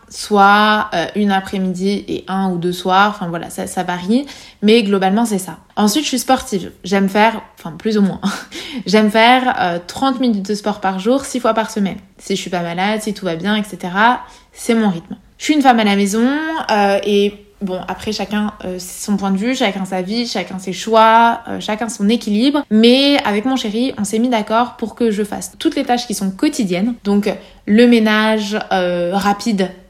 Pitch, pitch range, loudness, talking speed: 210 Hz, 195-235 Hz, -16 LUFS, 210 wpm